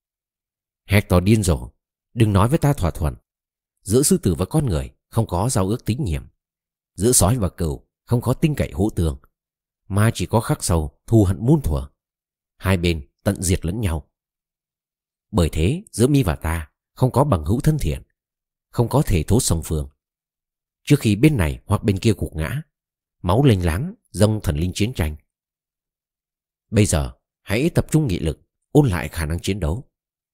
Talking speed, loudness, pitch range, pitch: 185 wpm, -20 LUFS, 80-120 Hz, 95 Hz